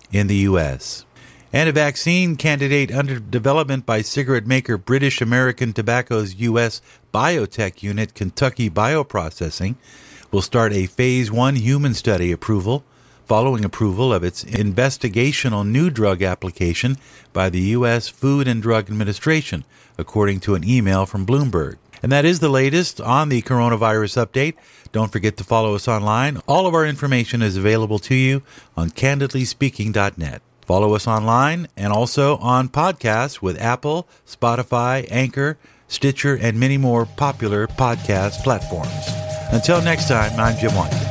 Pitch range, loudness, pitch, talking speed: 105-135 Hz, -19 LUFS, 120 Hz, 145 wpm